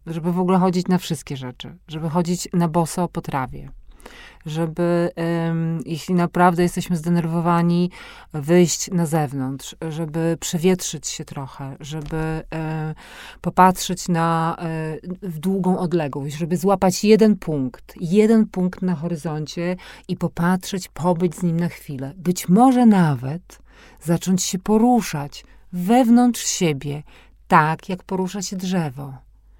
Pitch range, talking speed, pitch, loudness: 160-185 Hz, 120 wpm, 175 Hz, -20 LUFS